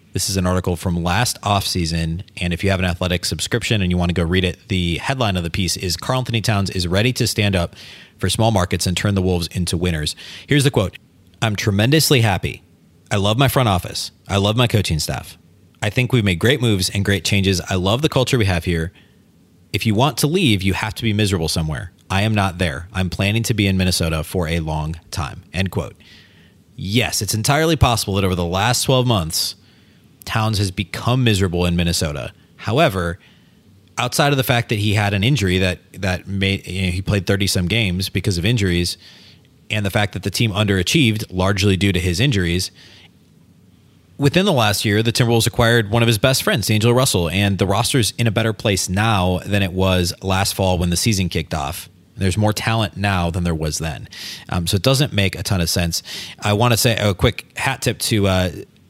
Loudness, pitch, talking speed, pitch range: -18 LUFS, 100 Hz, 215 wpm, 90-115 Hz